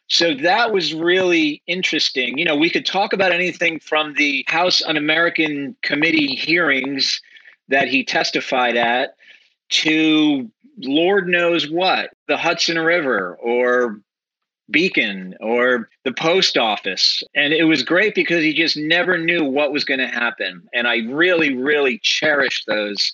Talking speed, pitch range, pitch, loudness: 145 wpm, 140-175 Hz, 160 Hz, -17 LUFS